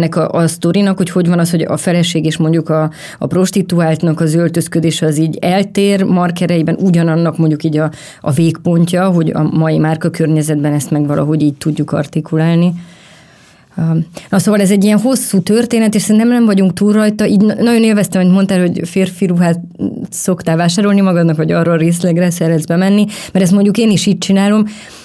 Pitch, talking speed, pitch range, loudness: 175 Hz, 175 wpm, 160-195 Hz, -12 LUFS